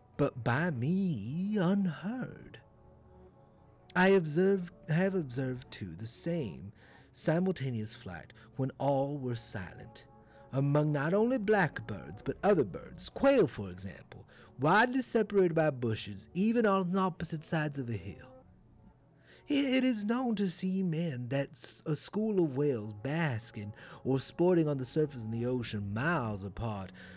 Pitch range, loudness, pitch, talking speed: 120-185 Hz, -32 LUFS, 145 Hz, 135 wpm